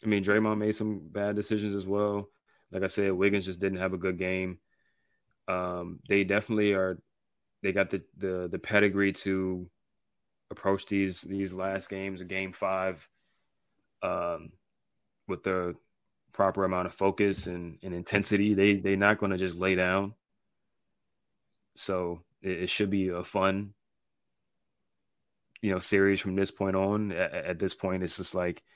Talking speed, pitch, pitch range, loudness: 160 wpm, 95 Hz, 95-100 Hz, -29 LUFS